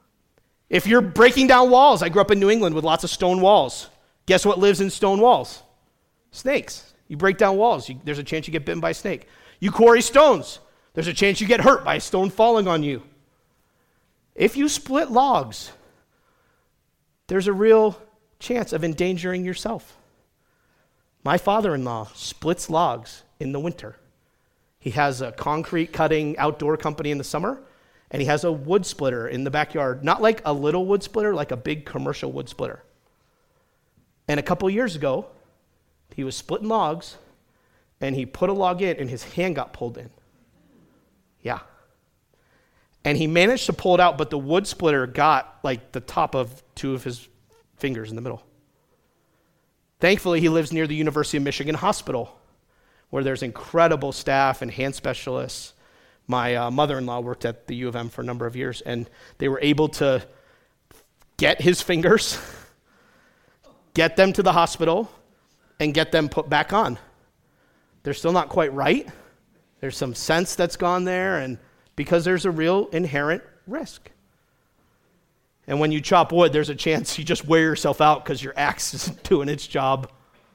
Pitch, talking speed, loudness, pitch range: 160 Hz, 175 wpm, -21 LUFS, 140-185 Hz